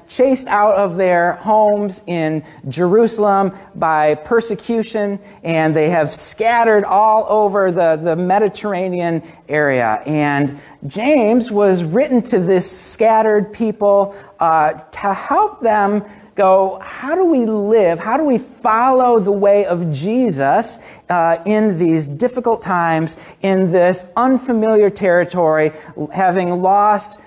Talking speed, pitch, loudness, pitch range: 120 wpm, 200 Hz, -15 LUFS, 170-220 Hz